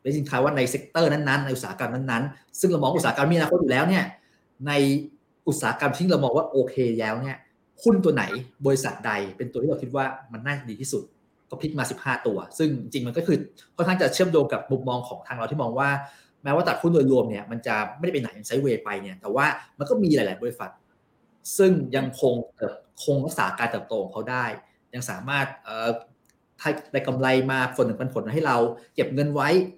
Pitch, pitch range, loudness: 135 Hz, 125-150 Hz, -25 LUFS